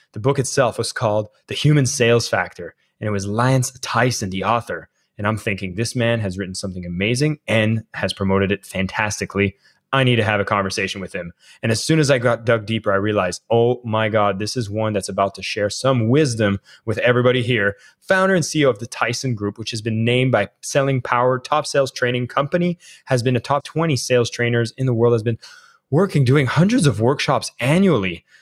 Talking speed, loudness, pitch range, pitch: 210 wpm, -19 LUFS, 105-130 Hz, 115 Hz